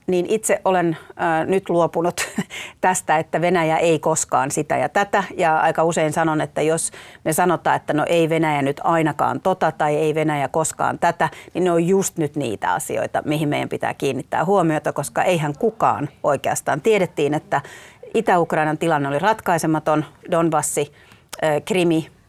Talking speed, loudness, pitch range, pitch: 160 wpm, -20 LUFS, 155-180 Hz, 165 Hz